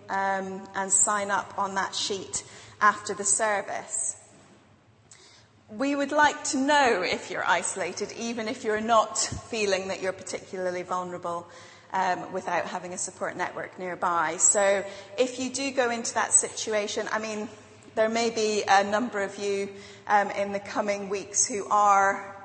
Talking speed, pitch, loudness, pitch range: 155 wpm, 200 Hz, -26 LUFS, 190-220 Hz